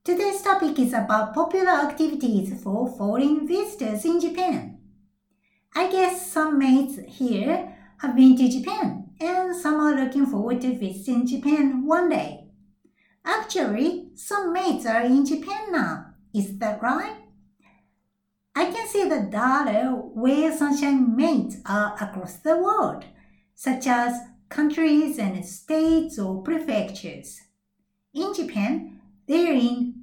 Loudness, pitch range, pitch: -23 LUFS, 210-320 Hz, 265 Hz